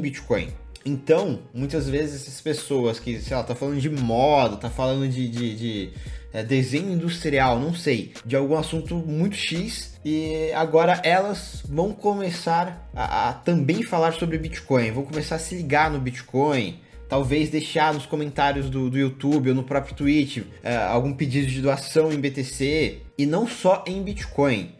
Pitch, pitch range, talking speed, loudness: 145 Hz, 130-160 Hz, 165 wpm, -24 LUFS